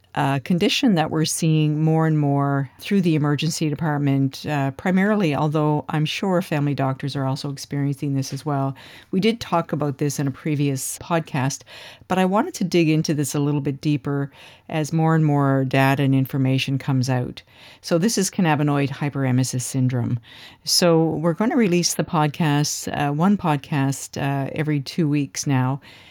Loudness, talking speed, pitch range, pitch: -21 LUFS, 170 wpm, 135-160 Hz, 145 Hz